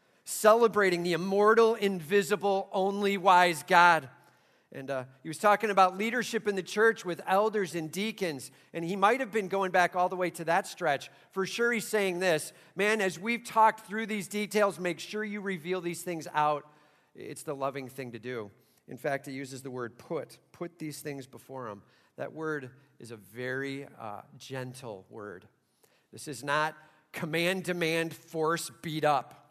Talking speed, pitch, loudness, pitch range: 175 wpm, 170 Hz, -29 LUFS, 140-200 Hz